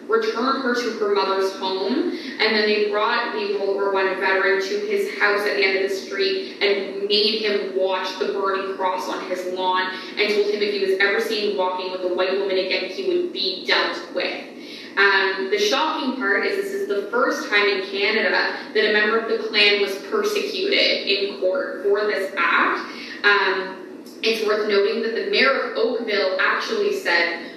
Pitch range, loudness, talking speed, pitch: 195-305 Hz, -20 LUFS, 195 wpm, 210 Hz